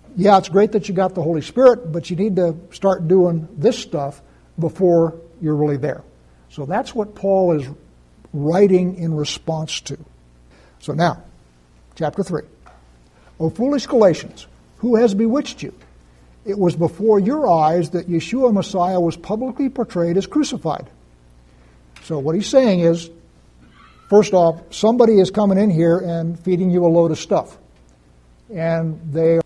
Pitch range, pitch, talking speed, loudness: 145-195 Hz, 170 Hz, 155 wpm, -18 LUFS